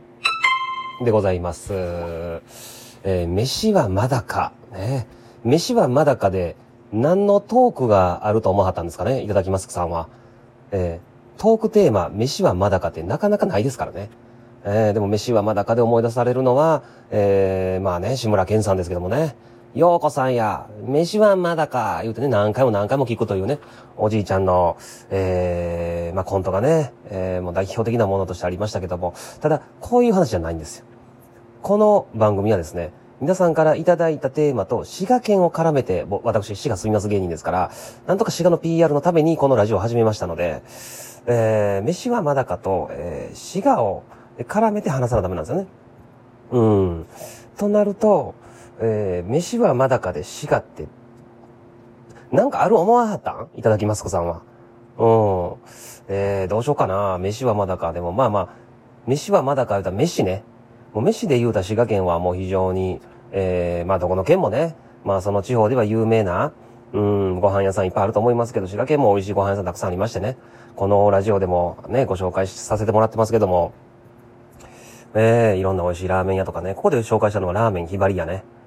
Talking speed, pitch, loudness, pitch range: 370 characters per minute, 115 Hz, -20 LUFS, 95-130 Hz